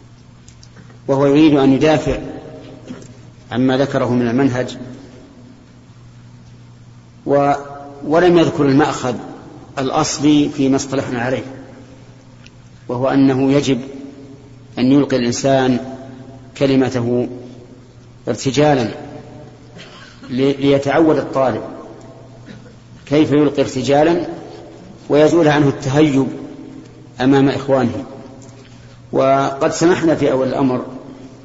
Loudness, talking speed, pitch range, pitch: -15 LUFS, 75 wpm, 125-140 Hz, 130 Hz